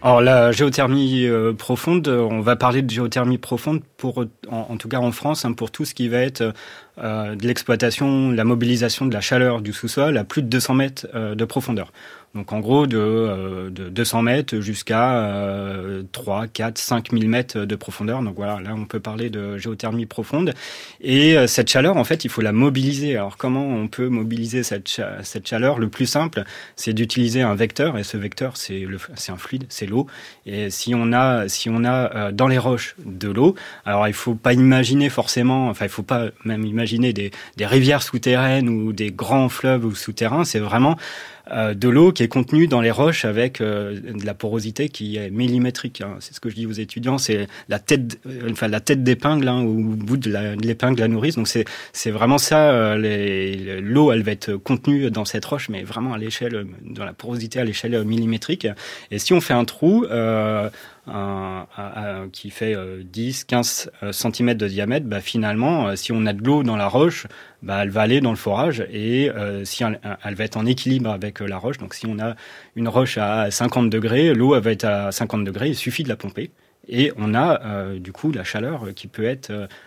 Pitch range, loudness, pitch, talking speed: 105-125 Hz, -20 LUFS, 115 Hz, 215 wpm